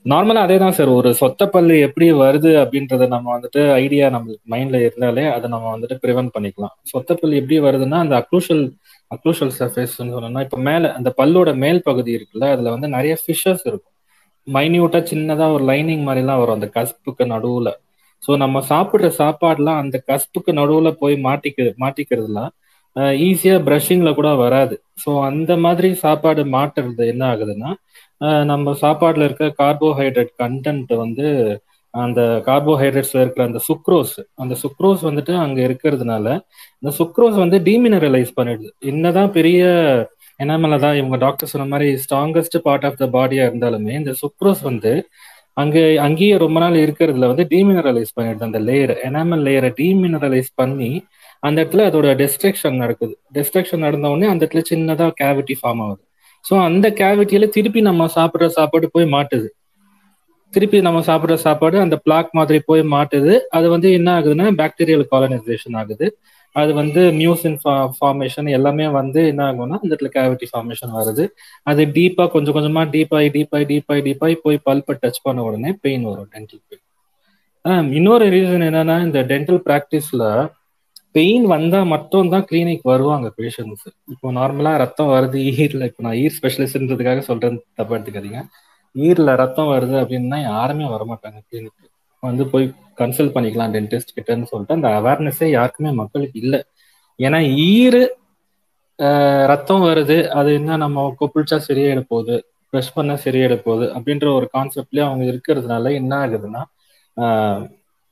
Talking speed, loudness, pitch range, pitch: 140 wpm, -16 LUFS, 130-160 Hz, 145 Hz